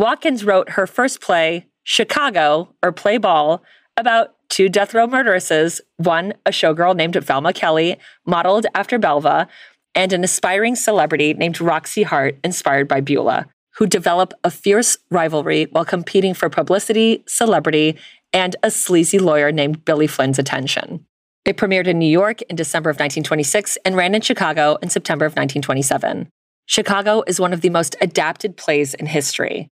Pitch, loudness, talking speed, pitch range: 180 Hz, -17 LUFS, 155 wpm, 155-205 Hz